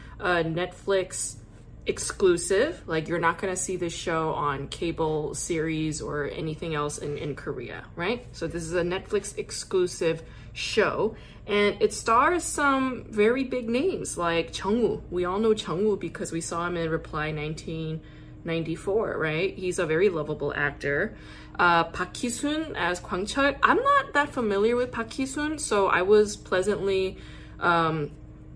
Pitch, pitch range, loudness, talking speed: 180 Hz, 160-220 Hz, -26 LUFS, 155 wpm